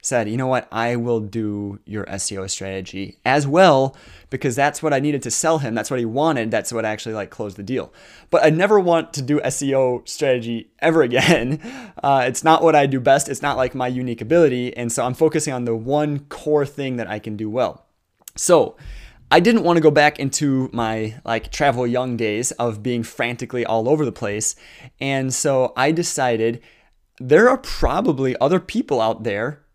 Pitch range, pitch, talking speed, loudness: 115-150 Hz, 130 Hz, 200 wpm, -19 LUFS